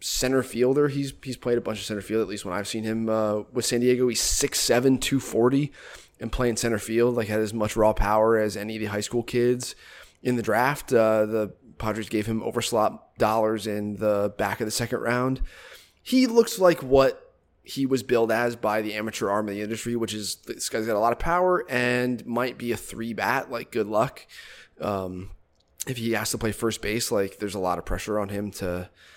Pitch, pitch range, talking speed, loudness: 115 Hz, 105-125 Hz, 220 wpm, -25 LUFS